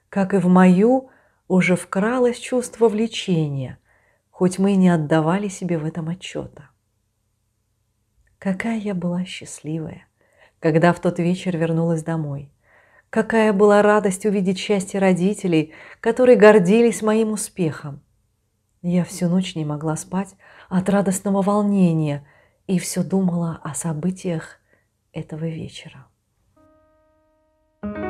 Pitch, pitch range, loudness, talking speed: 180 Hz, 160-210 Hz, -20 LUFS, 115 wpm